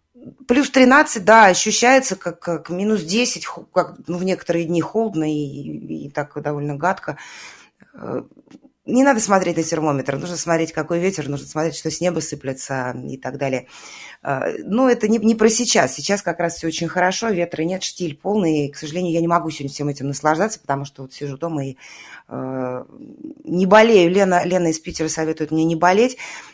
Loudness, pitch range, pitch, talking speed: -19 LUFS, 155-215 Hz, 170 Hz, 185 wpm